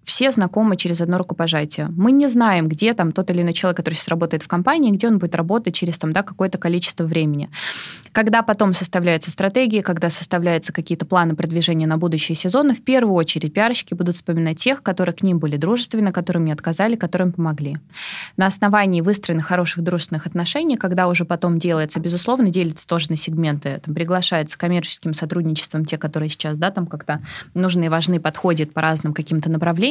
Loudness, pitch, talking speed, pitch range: -19 LUFS, 175 Hz, 185 wpm, 160-190 Hz